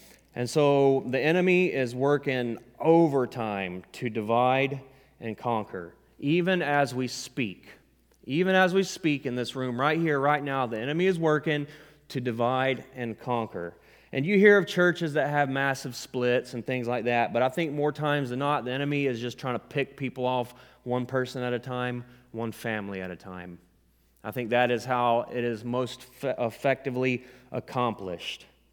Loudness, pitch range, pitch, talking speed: -27 LUFS, 120-145 Hz, 125 Hz, 175 wpm